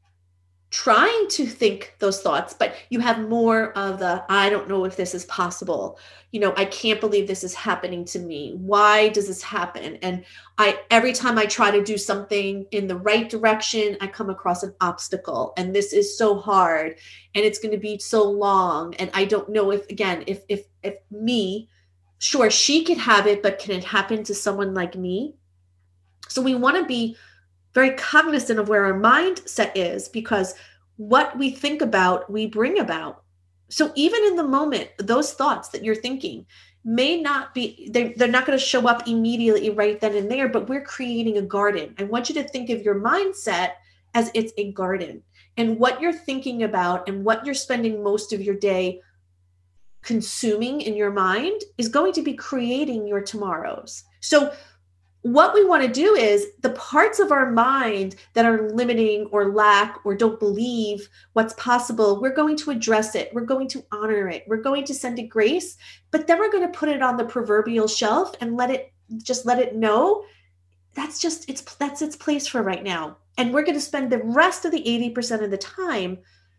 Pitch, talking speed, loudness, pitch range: 215 Hz, 195 wpm, -22 LUFS, 195-255 Hz